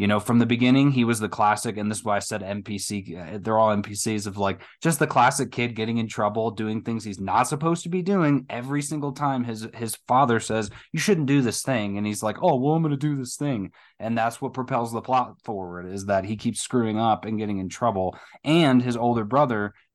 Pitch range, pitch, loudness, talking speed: 105-135 Hz, 115 Hz, -24 LUFS, 240 wpm